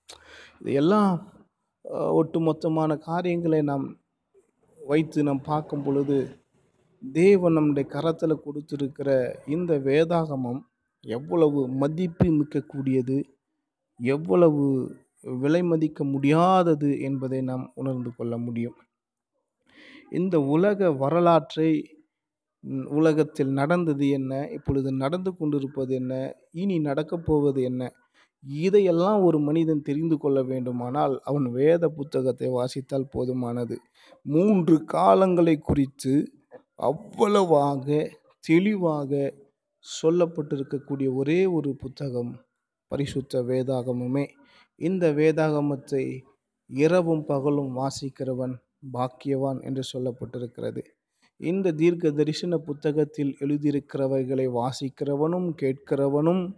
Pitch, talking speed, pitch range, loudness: 145 Hz, 80 wpm, 135-165 Hz, -25 LUFS